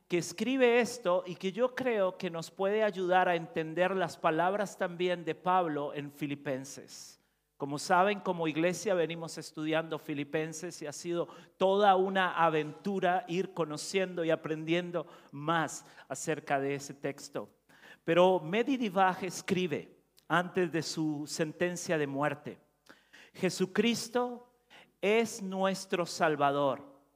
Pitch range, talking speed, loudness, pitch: 155-190 Hz, 120 wpm, -32 LUFS, 175 Hz